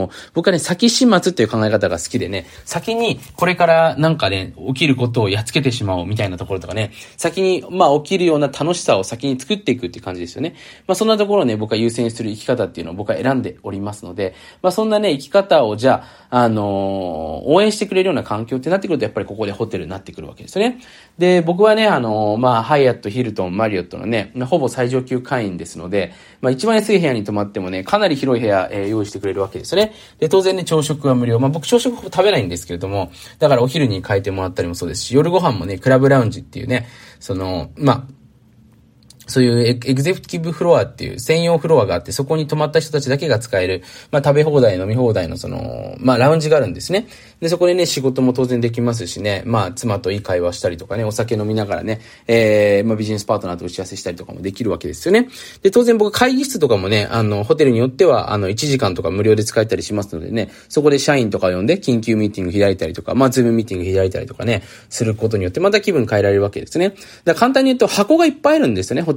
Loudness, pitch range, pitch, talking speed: -17 LUFS, 105-165 Hz, 125 Hz, 505 characters per minute